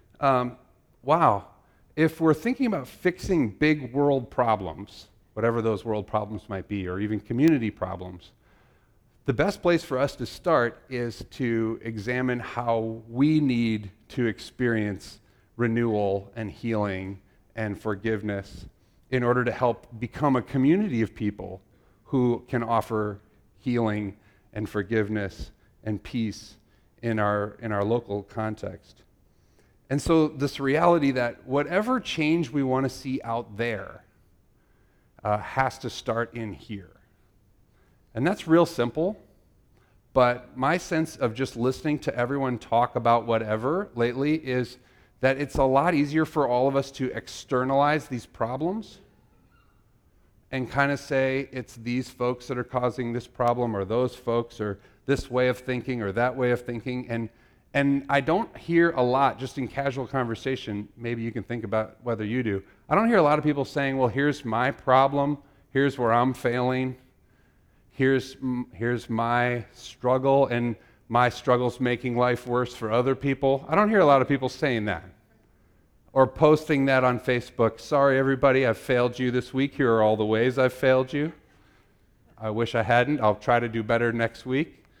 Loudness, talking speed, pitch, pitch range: -26 LUFS, 160 wpm, 120 Hz, 110-135 Hz